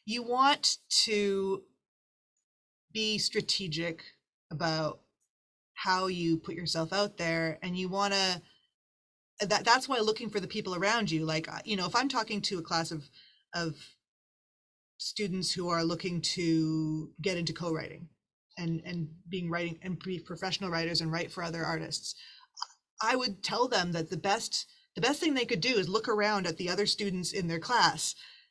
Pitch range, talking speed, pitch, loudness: 165-210 Hz, 170 wpm, 185 Hz, -31 LUFS